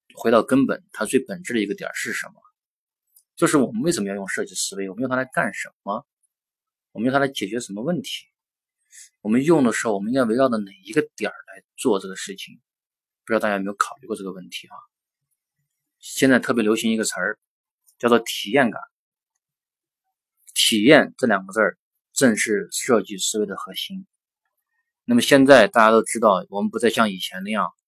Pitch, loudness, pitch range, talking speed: 130 Hz, -21 LUFS, 110-170 Hz, 290 characters per minute